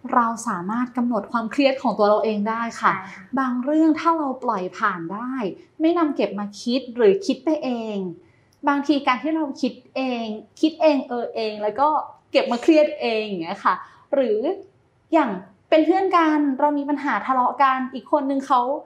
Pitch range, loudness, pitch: 225-300 Hz, -22 LUFS, 260 Hz